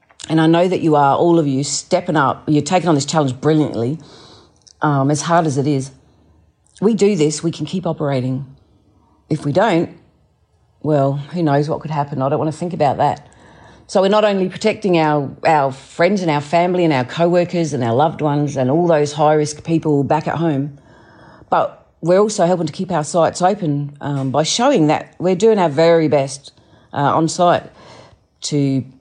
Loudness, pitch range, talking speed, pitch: -17 LUFS, 135-170 Hz, 200 wpm, 150 Hz